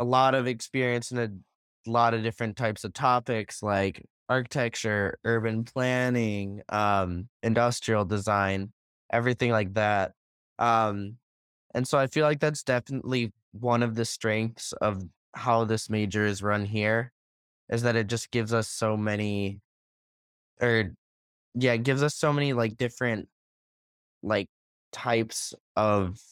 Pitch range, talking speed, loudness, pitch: 105-120 Hz, 140 wpm, -27 LUFS, 115 Hz